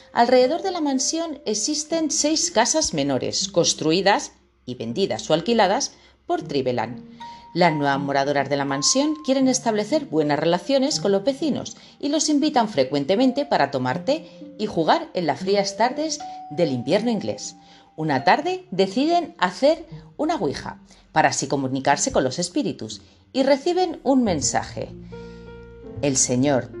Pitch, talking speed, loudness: 200 Hz, 140 wpm, -21 LUFS